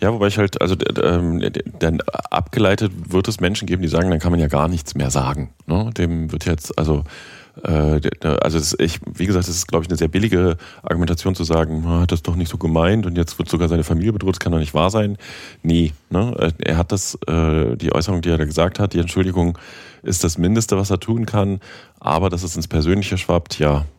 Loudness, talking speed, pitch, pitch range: -19 LUFS, 230 wpm, 85 Hz, 80-95 Hz